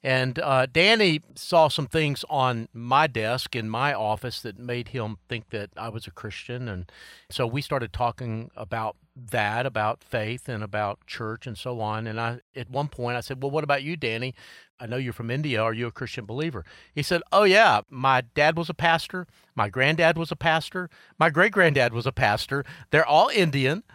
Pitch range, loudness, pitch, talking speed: 115-155 Hz, -24 LUFS, 130 Hz, 205 wpm